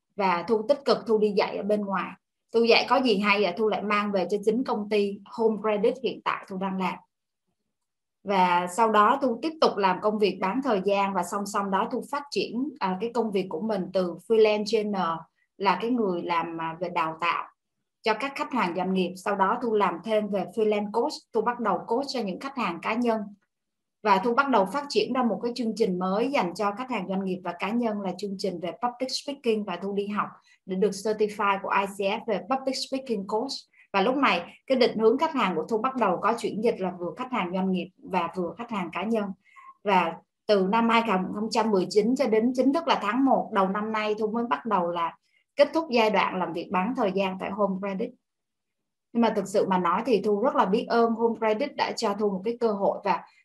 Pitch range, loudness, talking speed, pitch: 190-235 Hz, -26 LUFS, 235 wpm, 215 Hz